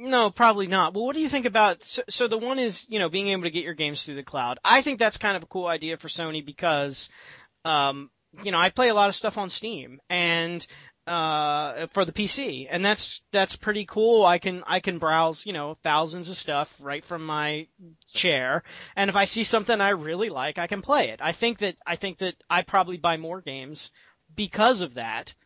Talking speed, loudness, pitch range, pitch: 230 wpm, -25 LUFS, 160-210 Hz, 180 Hz